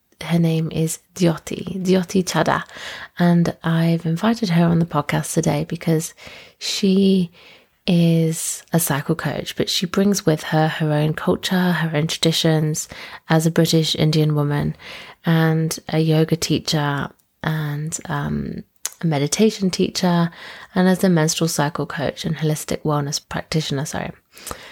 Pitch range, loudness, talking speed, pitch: 155-175 Hz, -20 LUFS, 135 wpm, 165 Hz